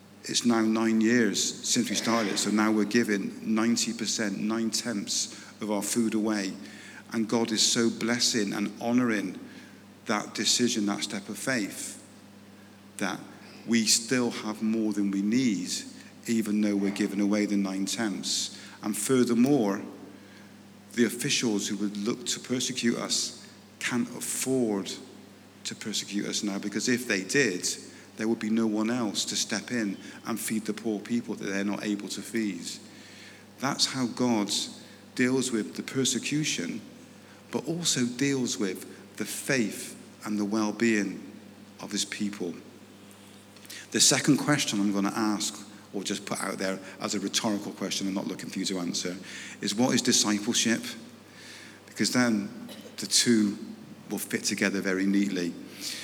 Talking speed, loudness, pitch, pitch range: 155 wpm, -28 LUFS, 105 Hz, 100-115 Hz